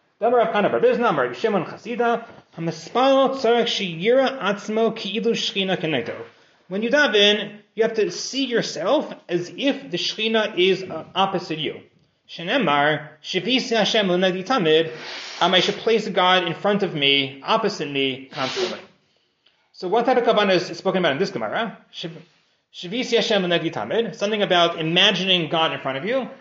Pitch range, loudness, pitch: 170-225 Hz, -21 LUFS, 195 Hz